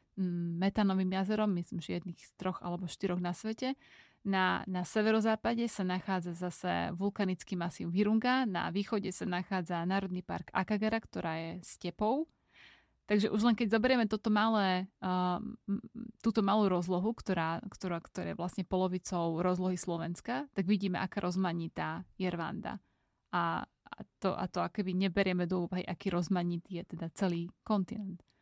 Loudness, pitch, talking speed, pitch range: -34 LUFS, 190 Hz, 150 wpm, 180-215 Hz